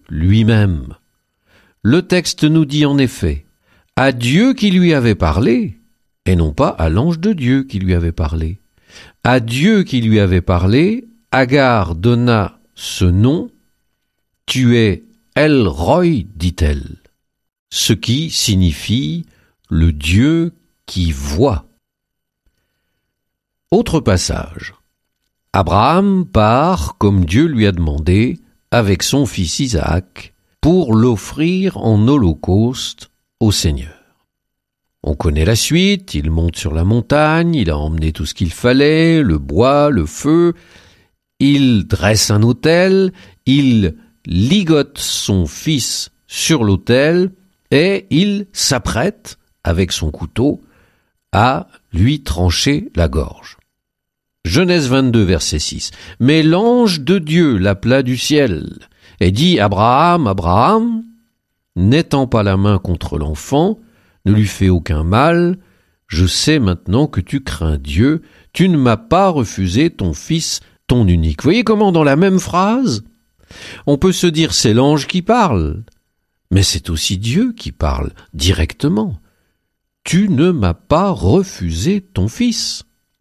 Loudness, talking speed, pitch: -14 LUFS, 125 wpm, 110 Hz